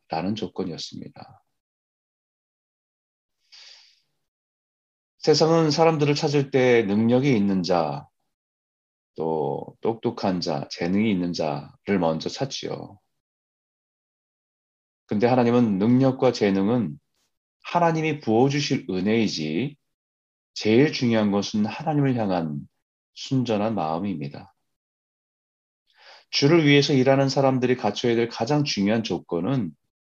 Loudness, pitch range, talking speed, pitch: -23 LUFS, 100-140 Hz, 220 characters per minute, 120 Hz